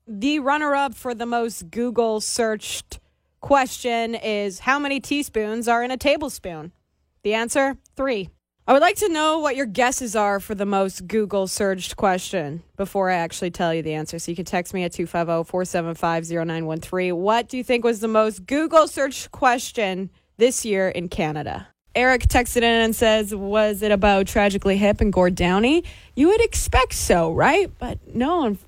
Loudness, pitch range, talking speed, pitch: -21 LUFS, 185-255 Hz, 180 wpm, 215 Hz